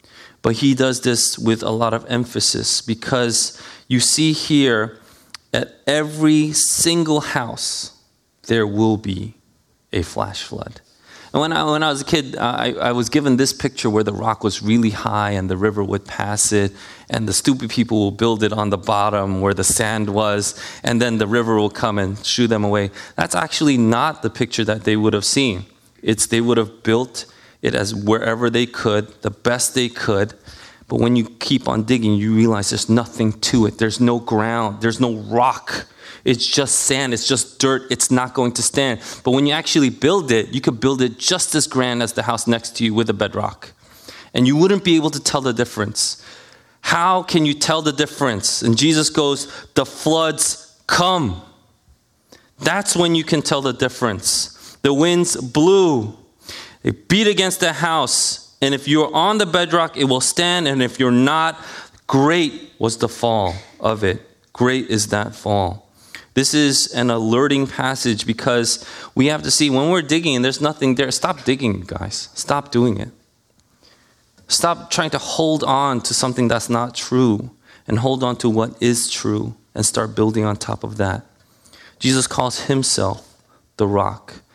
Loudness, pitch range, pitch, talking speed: -18 LUFS, 110-140 Hz, 120 Hz, 185 wpm